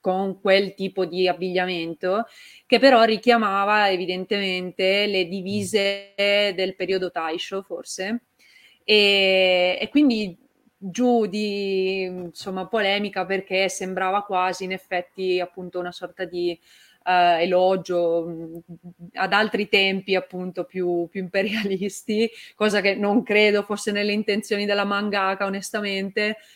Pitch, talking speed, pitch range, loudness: 195 Hz, 110 wpm, 185-205 Hz, -22 LUFS